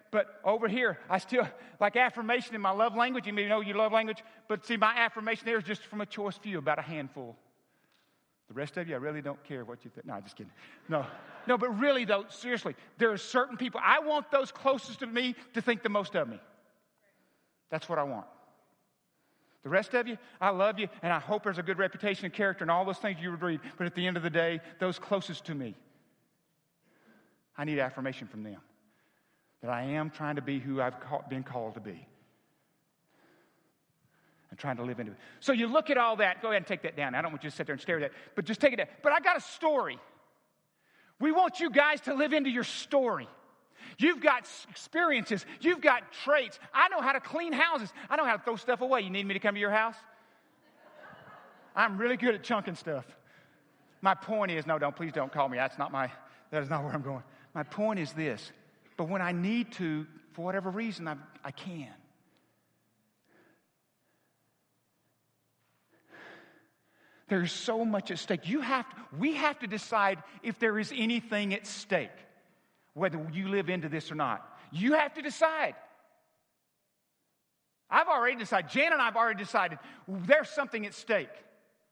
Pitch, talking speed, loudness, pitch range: 205 Hz, 205 wpm, -31 LUFS, 165-240 Hz